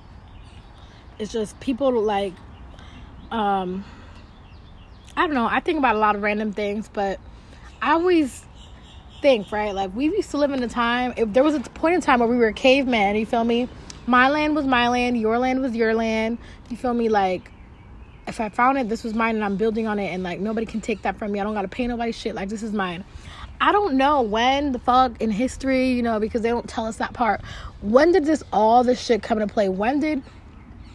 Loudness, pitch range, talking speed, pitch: -22 LUFS, 205-255 Hz, 225 wpm, 230 Hz